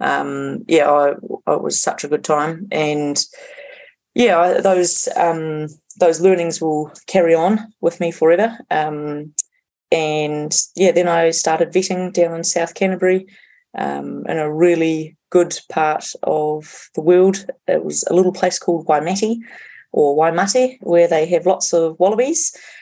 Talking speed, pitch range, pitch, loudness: 145 wpm, 155-185 Hz, 170 Hz, -17 LUFS